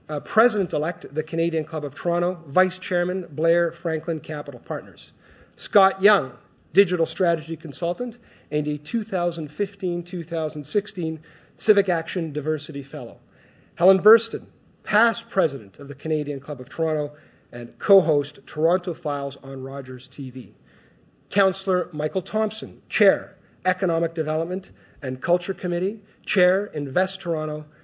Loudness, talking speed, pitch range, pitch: -23 LUFS, 125 wpm, 150-185 Hz, 165 Hz